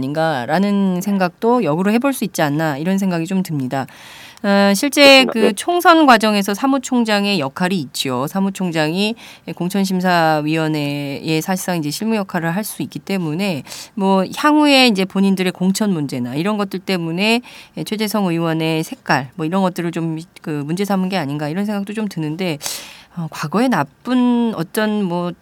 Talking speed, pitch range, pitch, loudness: 330 characters per minute, 160-210 Hz, 185 Hz, -17 LUFS